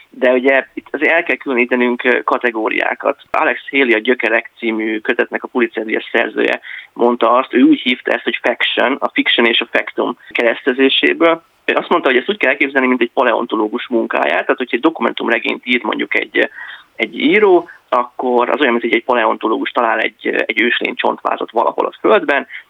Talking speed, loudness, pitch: 175 wpm, -15 LUFS, 125 Hz